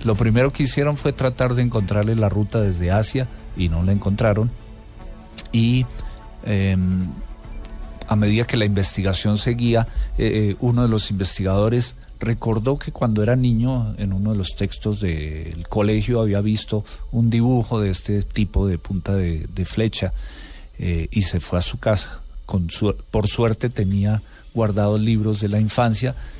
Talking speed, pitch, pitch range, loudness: 160 wpm, 105 Hz, 95-115 Hz, -21 LUFS